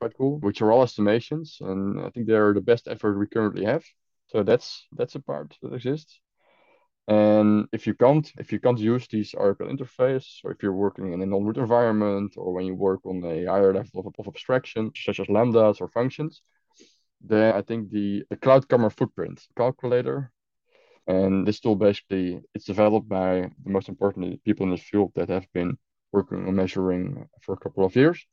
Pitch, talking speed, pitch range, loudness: 105 Hz, 200 wpm, 95-125 Hz, -24 LUFS